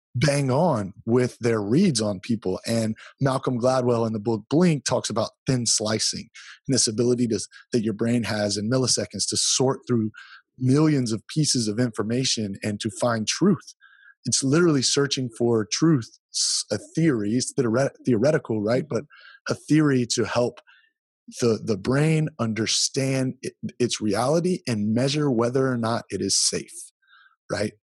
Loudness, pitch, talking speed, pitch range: -23 LUFS, 125 Hz, 155 wpm, 110-140 Hz